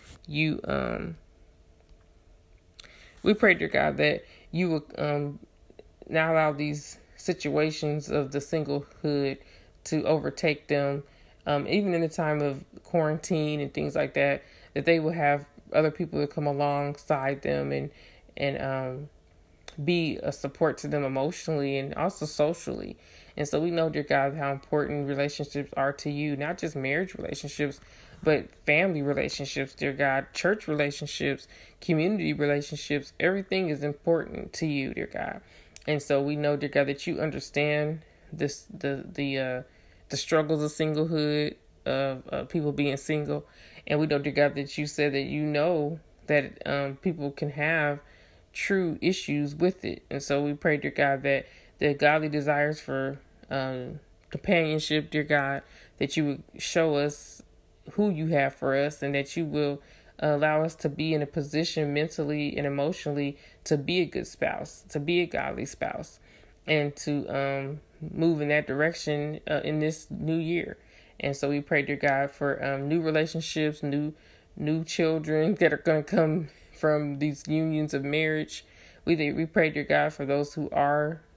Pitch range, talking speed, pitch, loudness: 140-155 Hz, 165 wpm, 150 Hz, -28 LUFS